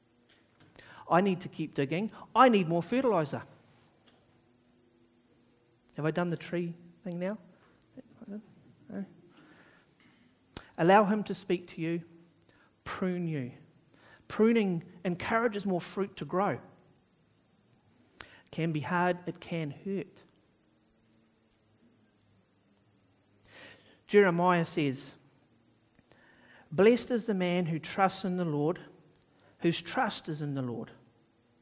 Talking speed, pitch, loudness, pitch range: 105 wpm, 165 Hz, -30 LUFS, 120-185 Hz